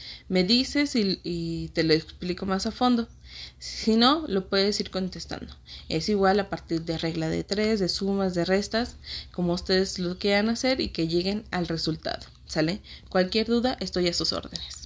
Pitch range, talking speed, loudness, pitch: 165-210 Hz, 180 wpm, -26 LUFS, 185 Hz